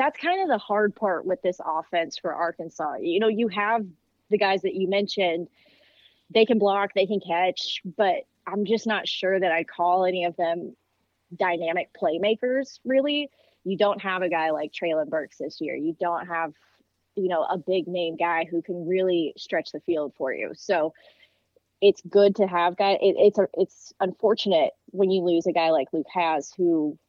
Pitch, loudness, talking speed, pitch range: 185 Hz, -25 LUFS, 195 wpm, 170-205 Hz